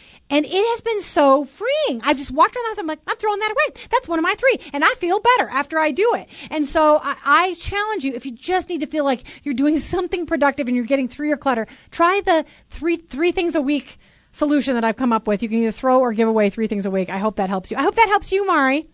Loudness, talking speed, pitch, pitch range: -19 LUFS, 285 wpm, 300 Hz, 265-365 Hz